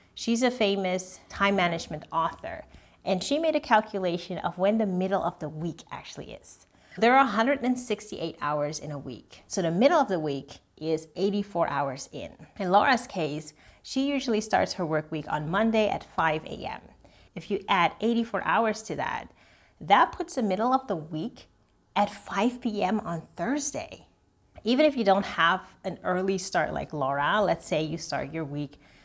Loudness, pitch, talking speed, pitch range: -27 LUFS, 195 Hz, 180 wpm, 160-230 Hz